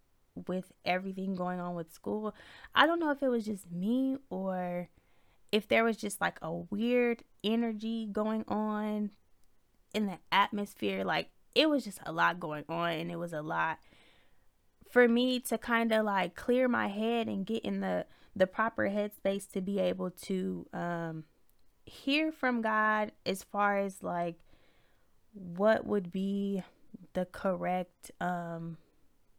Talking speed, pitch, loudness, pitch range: 155 wpm, 200 Hz, -32 LUFS, 175-225 Hz